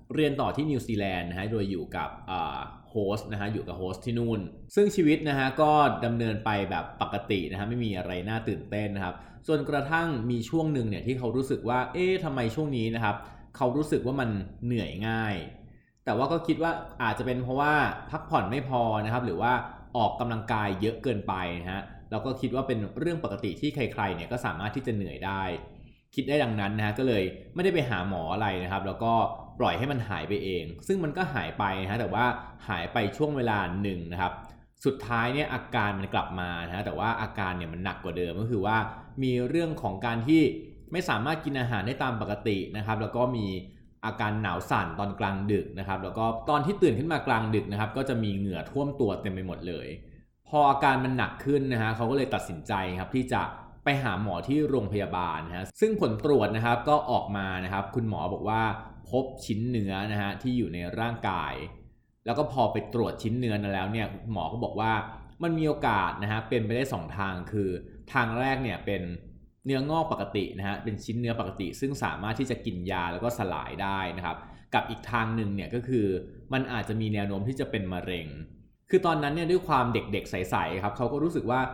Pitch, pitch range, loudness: 110 Hz, 100-130 Hz, -29 LUFS